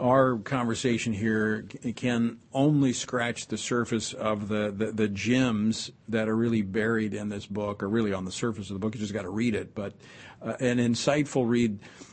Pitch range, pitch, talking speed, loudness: 110-125 Hz, 115 Hz, 195 wpm, -28 LUFS